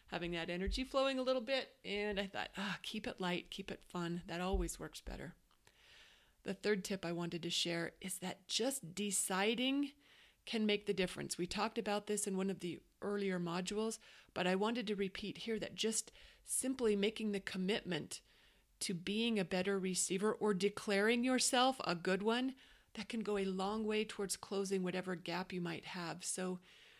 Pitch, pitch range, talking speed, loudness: 200 Hz, 185-220 Hz, 185 wpm, -39 LUFS